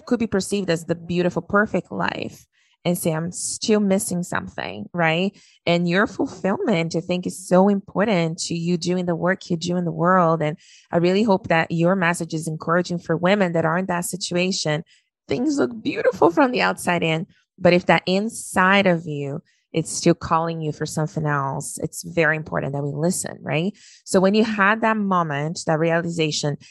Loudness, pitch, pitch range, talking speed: -21 LUFS, 175 Hz, 165-190 Hz, 190 wpm